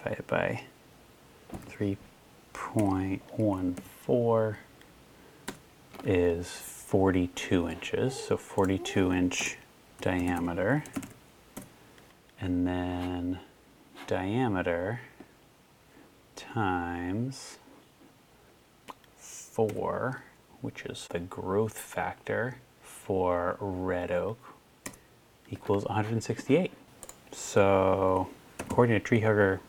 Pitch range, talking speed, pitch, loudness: 90-105 Hz, 60 wpm, 95 Hz, -30 LUFS